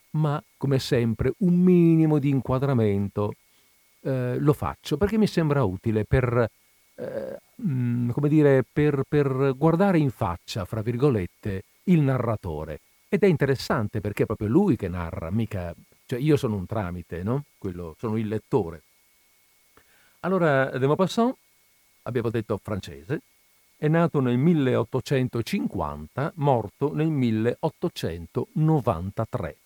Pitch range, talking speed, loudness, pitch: 105-150 Hz, 125 wpm, -25 LUFS, 125 Hz